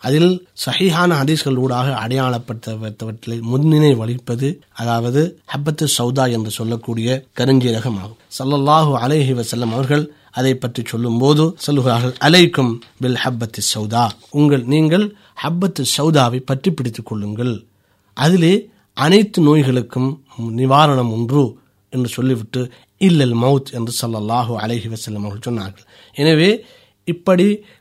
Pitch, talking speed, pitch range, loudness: 130 Hz, 105 wpm, 115-150 Hz, -17 LUFS